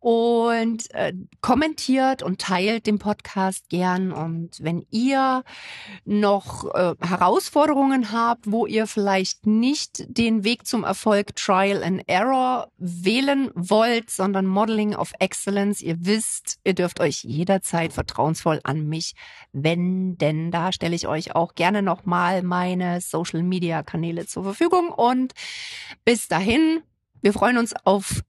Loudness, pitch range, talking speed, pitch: -22 LUFS, 175-230 Hz, 135 wpm, 195 Hz